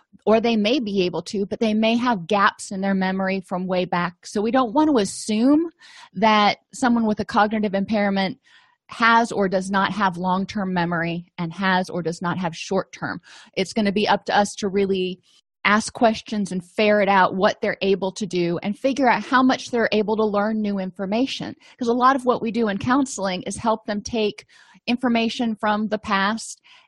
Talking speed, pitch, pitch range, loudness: 200 wpm, 210 Hz, 190-230 Hz, -21 LUFS